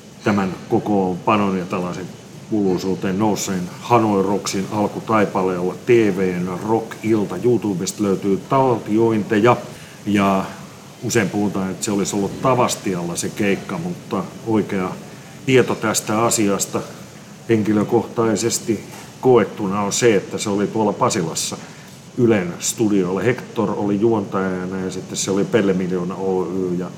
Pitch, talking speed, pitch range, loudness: 100 Hz, 120 wpm, 95-110 Hz, -19 LUFS